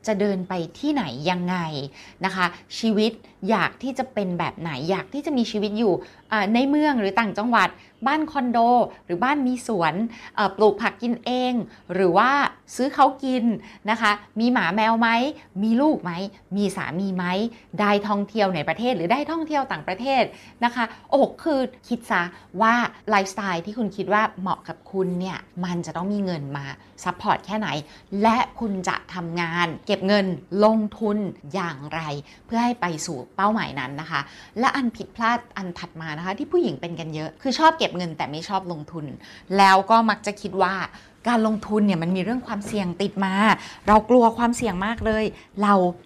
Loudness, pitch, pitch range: -23 LUFS, 205 Hz, 180-230 Hz